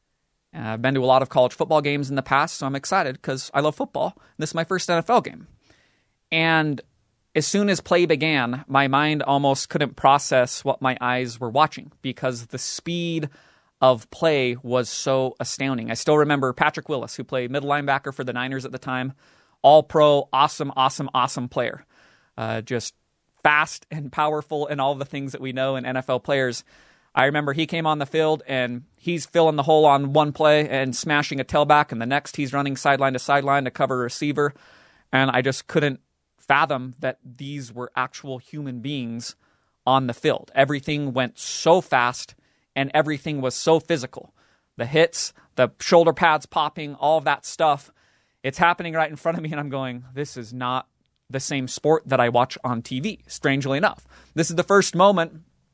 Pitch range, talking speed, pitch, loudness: 130-155 Hz, 195 wpm, 140 Hz, -22 LUFS